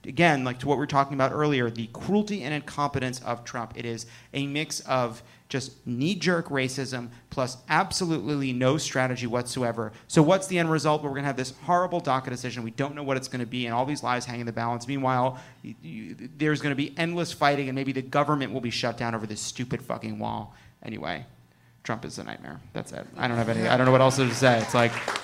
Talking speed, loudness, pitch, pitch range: 235 wpm, -27 LUFS, 130 Hz, 120-145 Hz